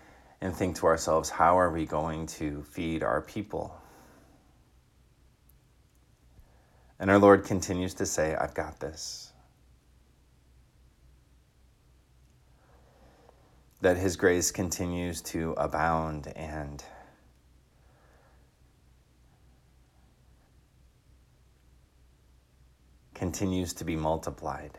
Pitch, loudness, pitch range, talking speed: 70 Hz, -29 LUFS, 65-85 Hz, 75 wpm